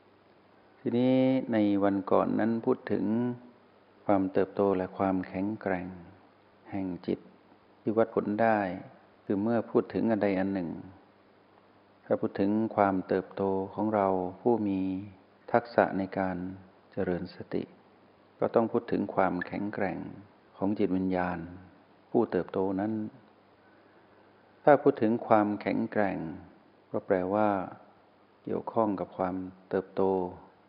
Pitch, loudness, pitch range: 100 Hz, -30 LUFS, 95-110 Hz